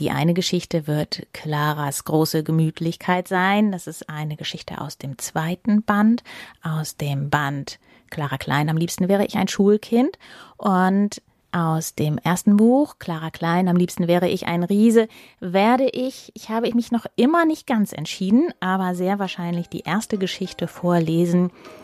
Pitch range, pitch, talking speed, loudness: 160-205 Hz, 180 Hz, 155 wpm, -21 LUFS